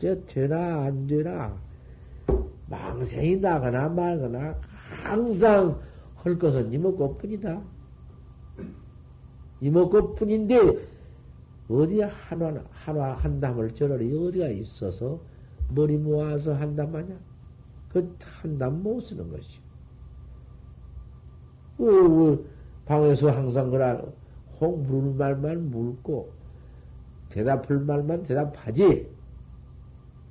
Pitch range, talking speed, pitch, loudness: 120-165 Hz, 175 characters per minute, 145 Hz, -25 LUFS